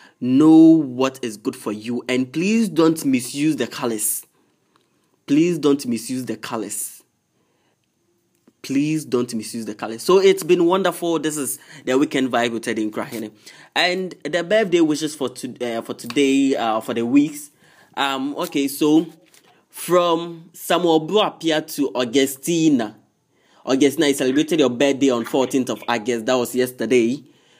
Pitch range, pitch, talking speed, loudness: 125-165 Hz, 140 Hz, 145 wpm, -19 LUFS